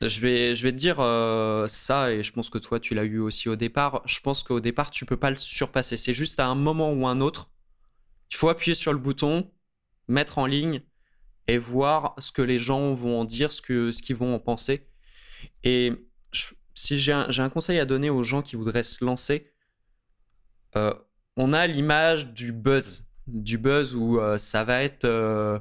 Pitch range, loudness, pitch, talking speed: 115-140 Hz, -25 LUFS, 125 Hz, 215 wpm